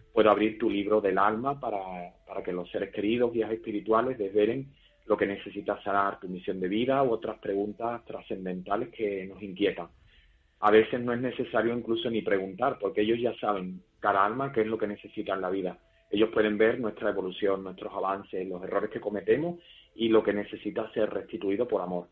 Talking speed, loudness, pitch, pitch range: 195 wpm, -29 LUFS, 105 Hz, 95-115 Hz